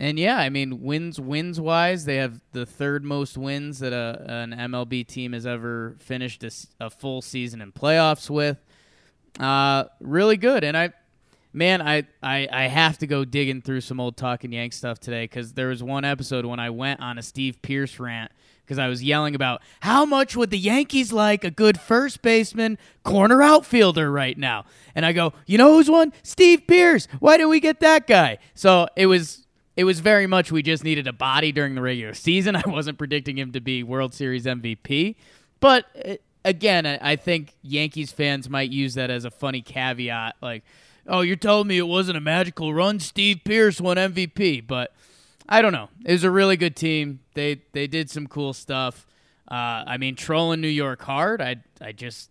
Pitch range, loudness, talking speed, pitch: 130-185 Hz, -21 LUFS, 195 wpm, 145 Hz